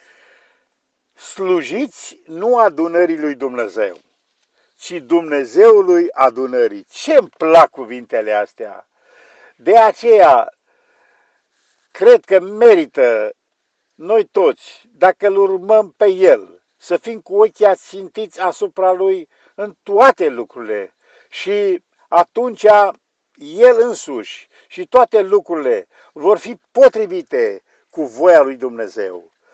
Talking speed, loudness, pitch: 100 wpm, -14 LUFS, 230 Hz